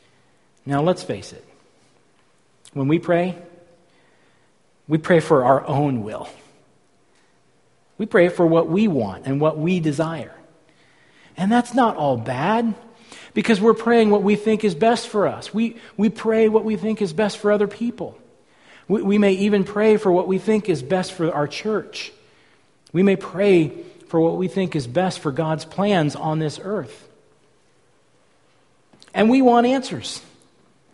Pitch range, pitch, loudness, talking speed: 160-220 Hz, 190 Hz, -20 LUFS, 160 wpm